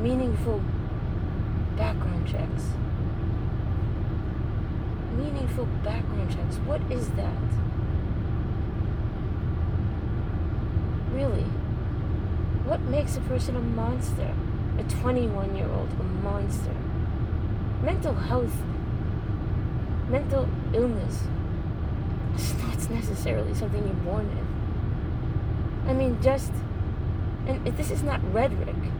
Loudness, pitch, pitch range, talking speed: -28 LUFS, 105 Hz, 95-110 Hz, 85 wpm